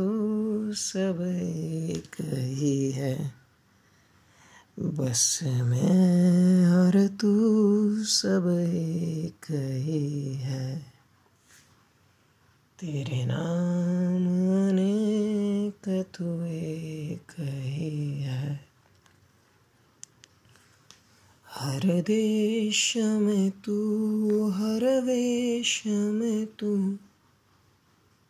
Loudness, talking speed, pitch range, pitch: -26 LUFS, 55 wpm, 130-205 Hz, 165 Hz